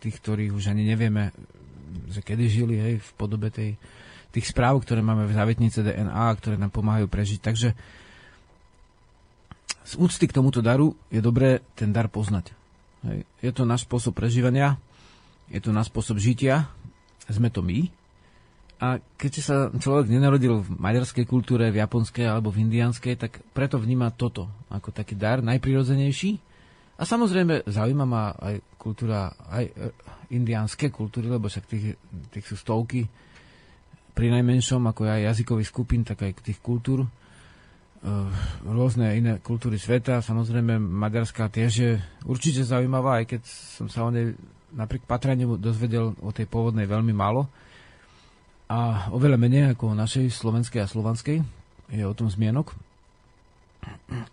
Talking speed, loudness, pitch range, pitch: 145 wpm, -25 LUFS, 105-125 Hz, 115 Hz